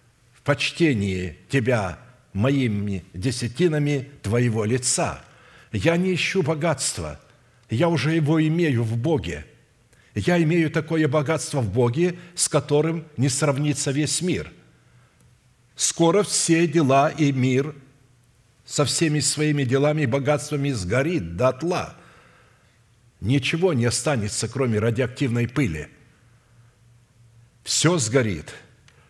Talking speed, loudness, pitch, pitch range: 105 wpm, -22 LUFS, 135 Hz, 120-155 Hz